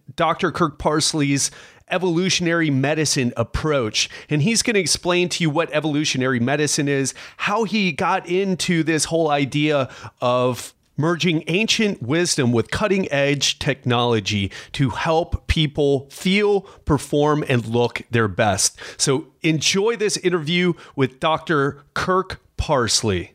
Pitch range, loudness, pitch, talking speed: 135-175 Hz, -20 LUFS, 150 Hz, 125 wpm